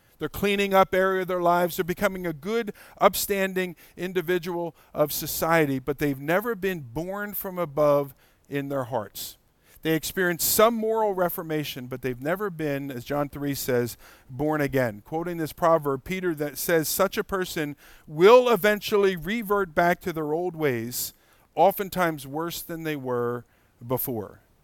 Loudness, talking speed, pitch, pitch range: -25 LUFS, 155 wpm, 165 Hz, 140-185 Hz